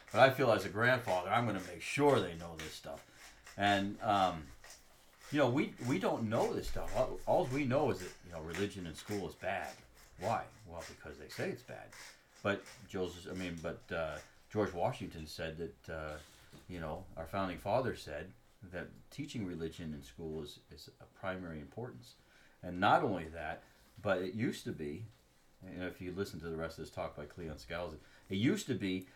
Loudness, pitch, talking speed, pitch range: -37 LUFS, 90 Hz, 200 wpm, 80-100 Hz